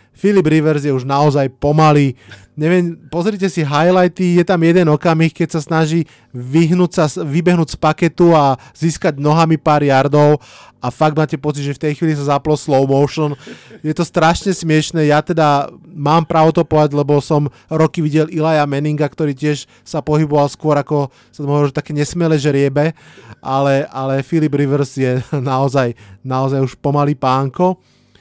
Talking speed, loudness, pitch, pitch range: 165 wpm, -15 LUFS, 150 Hz, 140-160 Hz